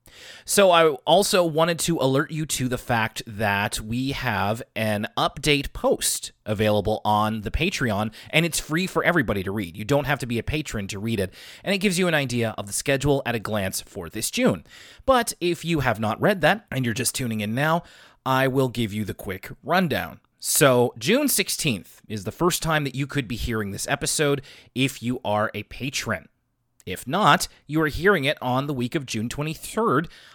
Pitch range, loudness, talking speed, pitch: 110-155 Hz, -23 LUFS, 205 wpm, 130 Hz